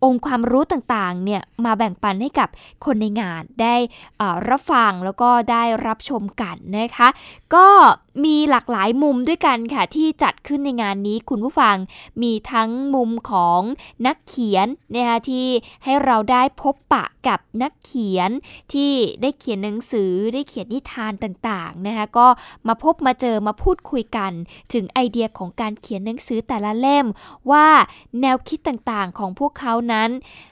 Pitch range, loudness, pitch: 220-270 Hz, -19 LUFS, 240 Hz